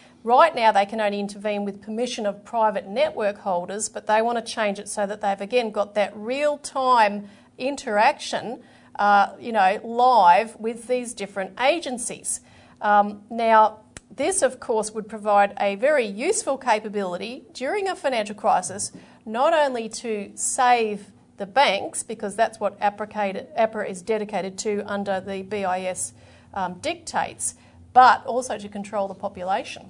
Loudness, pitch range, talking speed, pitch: -23 LUFS, 200-240 Hz, 145 wpm, 215 Hz